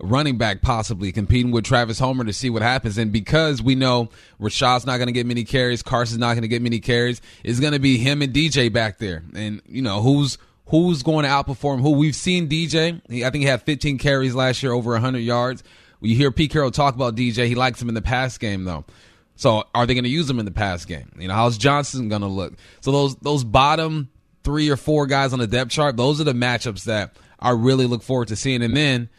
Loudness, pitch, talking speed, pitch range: -20 LUFS, 125 Hz, 245 wpm, 115-140 Hz